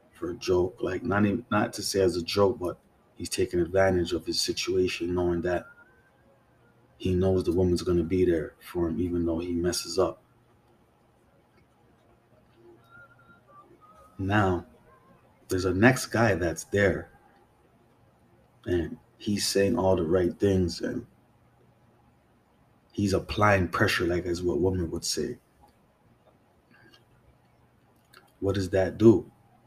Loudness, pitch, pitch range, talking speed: -27 LUFS, 95 Hz, 90-115 Hz, 125 wpm